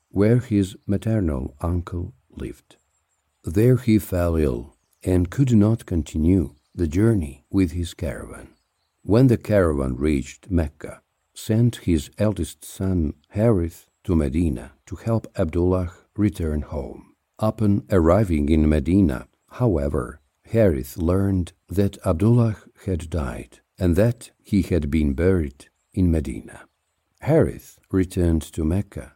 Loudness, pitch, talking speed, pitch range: -22 LUFS, 90 Hz, 120 wpm, 80-105 Hz